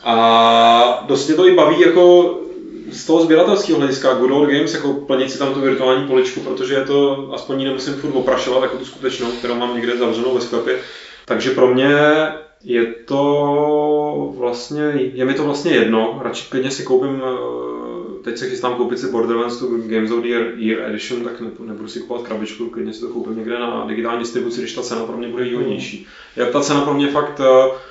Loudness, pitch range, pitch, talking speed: -17 LUFS, 120-145 Hz, 130 Hz, 195 wpm